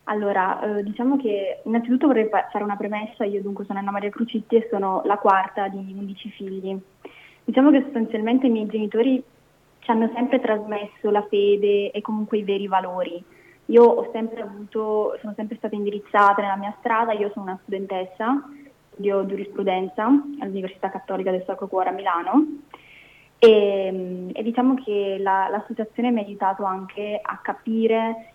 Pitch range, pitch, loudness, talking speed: 195-225 Hz, 210 Hz, -22 LUFS, 160 wpm